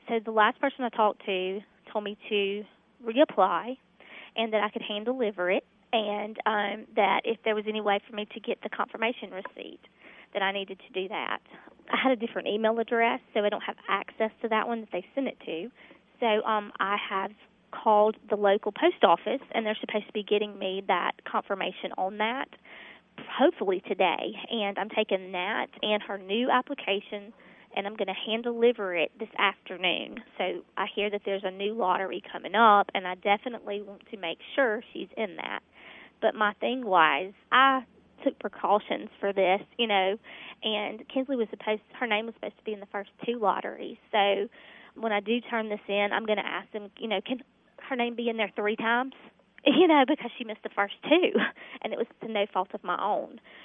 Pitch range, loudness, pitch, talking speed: 200-235 Hz, -28 LUFS, 215 Hz, 205 wpm